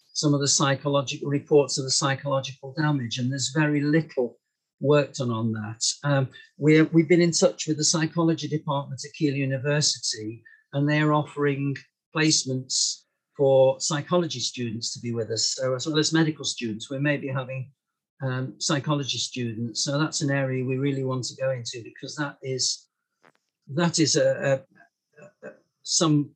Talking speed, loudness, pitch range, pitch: 165 wpm, -24 LUFS, 130-150 Hz, 140 Hz